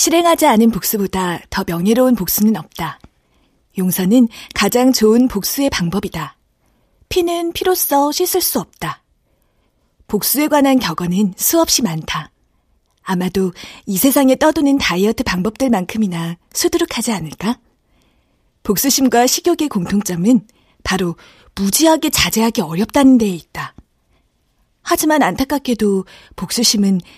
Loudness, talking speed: -15 LUFS, 280 characters per minute